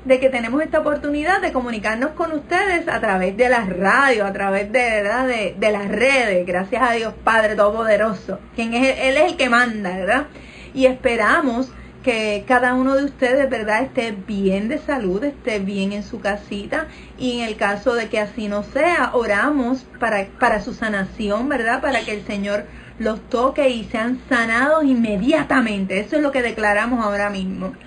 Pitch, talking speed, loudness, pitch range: 235 Hz, 180 wpm, -19 LUFS, 205-265 Hz